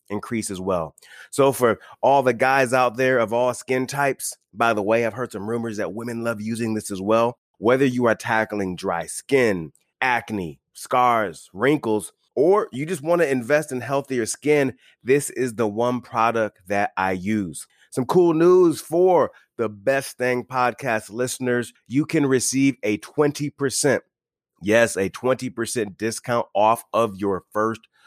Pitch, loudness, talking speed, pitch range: 120 Hz, -22 LUFS, 160 wpm, 110-135 Hz